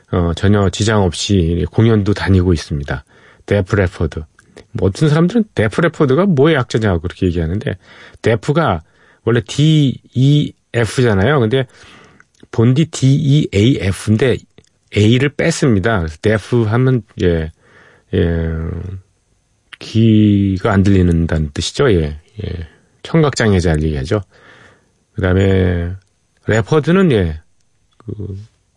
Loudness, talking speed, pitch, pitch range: -15 LUFS, 250 characters per minute, 105 Hz, 90-120 Hz